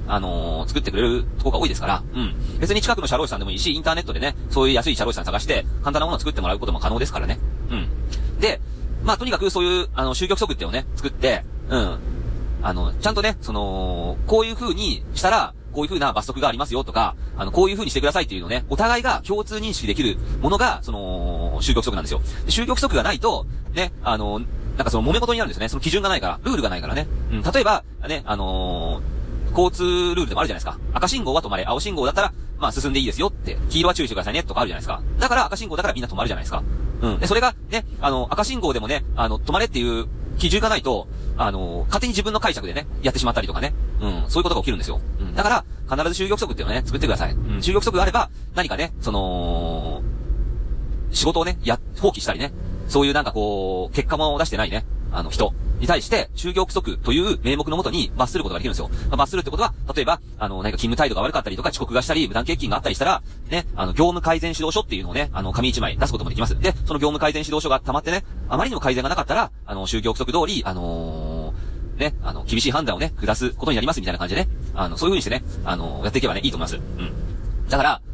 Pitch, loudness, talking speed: 125 Hz, -22 LUFS, 515 characters per minute